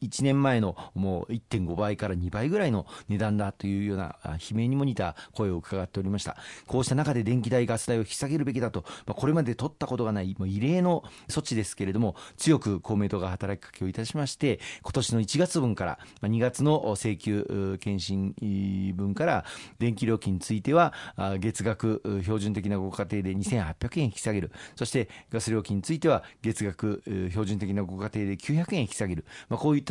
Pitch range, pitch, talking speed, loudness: 100-125 Hz, 105 Hz, 355 characters per minute, -29 LUFS